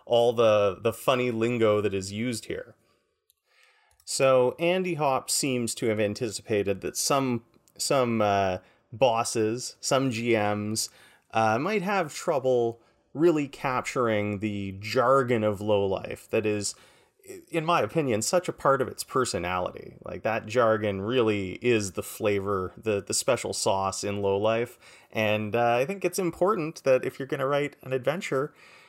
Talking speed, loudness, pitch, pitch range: 150 wpm, -26 LUFS, 115 Hz, 105-135 Hz